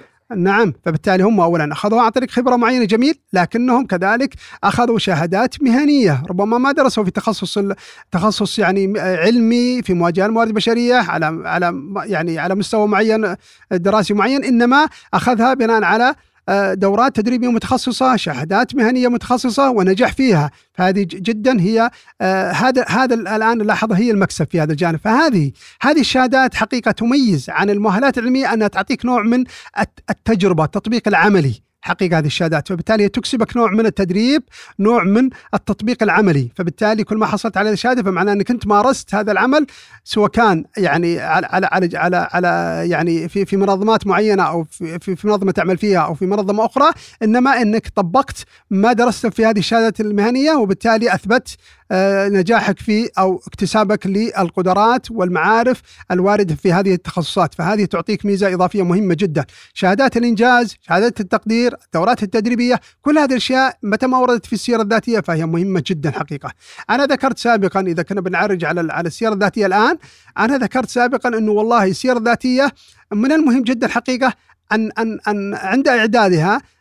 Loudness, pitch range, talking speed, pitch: -16 LUFS, 190-240 Hz, 150 wpm, 215 Hz